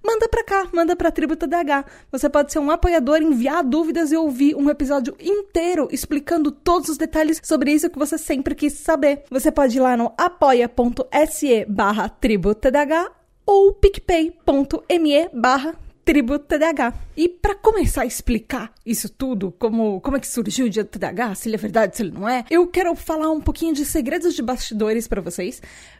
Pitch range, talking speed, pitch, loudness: 245-330 Hz, 175 wpm, 295 Hz, -20 LUFS